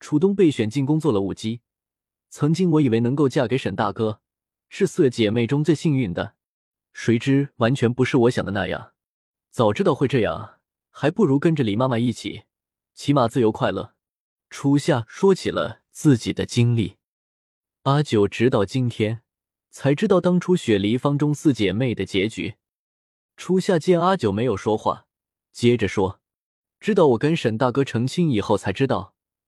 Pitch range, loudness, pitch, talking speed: 105-150 Hz, -21 LUFS, 120 Hz, 245 characters per minute